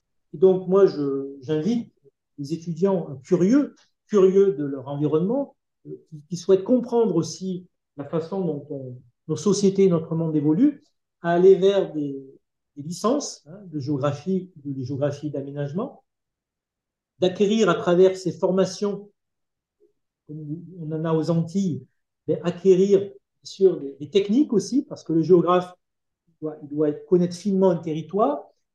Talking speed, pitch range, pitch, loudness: 140 wpm, 150-195 Hz, 175 Hz, -22 LUFS